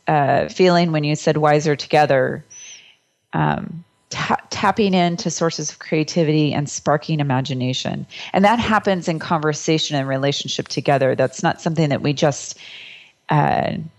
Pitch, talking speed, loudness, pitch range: 155 Hz, 135 wpm, -19 LUFS, 145-175 Hz